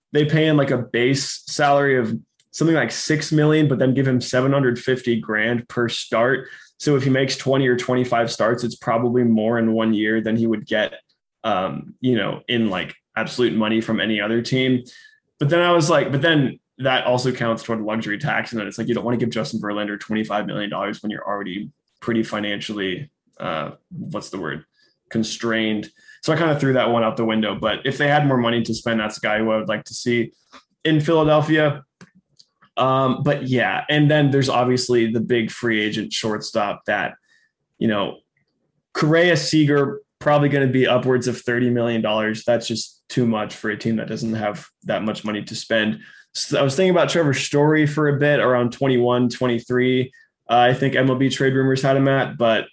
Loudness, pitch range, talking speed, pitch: -20 LUFS, 110-140 Hz, 205 wpm, 125 Hz